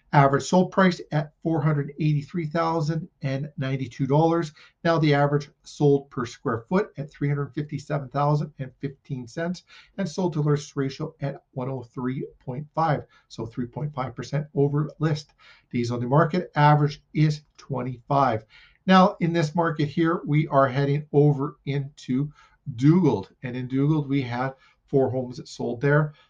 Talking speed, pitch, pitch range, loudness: 160 wpm, 145 Hz, 135-155 Hz, -25 LUFS